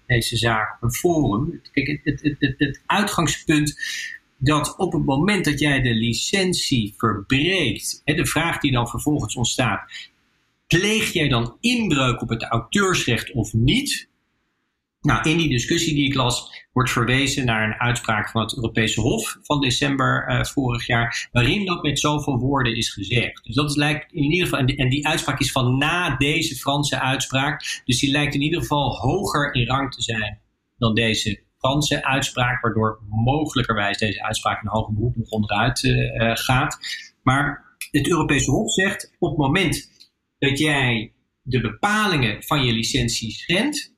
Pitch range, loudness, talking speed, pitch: 115-150 Hz, -21 LUFS, 170 wpm, 135 Hz